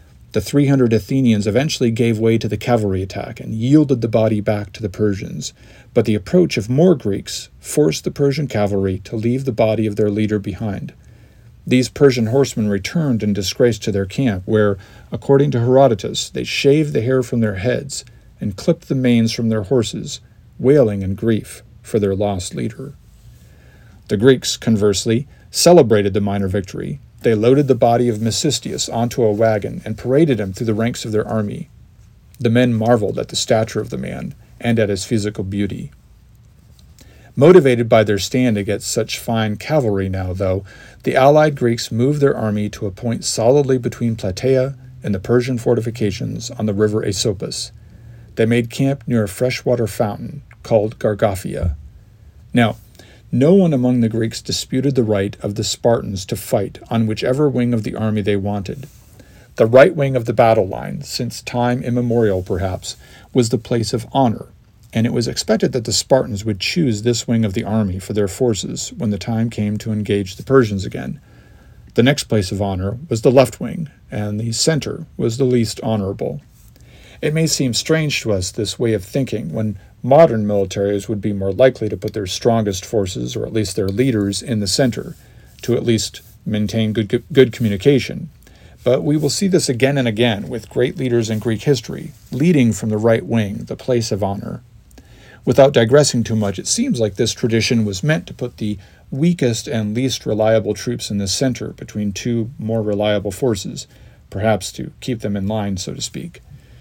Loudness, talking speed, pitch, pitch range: -18 LUFS, 185 wpm, 115 Hz, 105-125 Hz